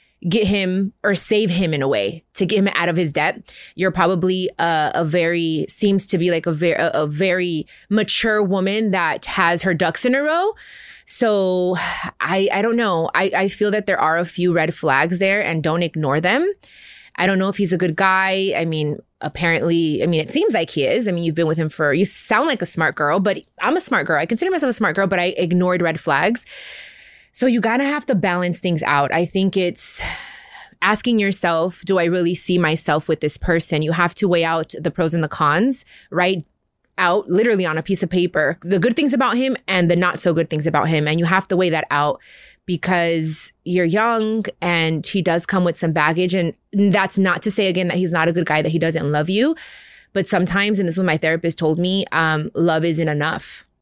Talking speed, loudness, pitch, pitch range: 225 wpm, -18 LUFS, 180 Hz, 165-195 Hz